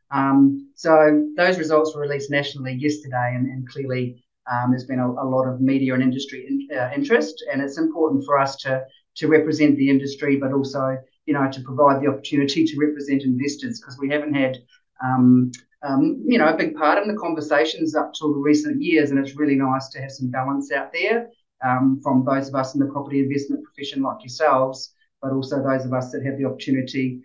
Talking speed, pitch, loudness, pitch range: 210 wpm, 140 Hz, -21 LUFS, 130-150 Hz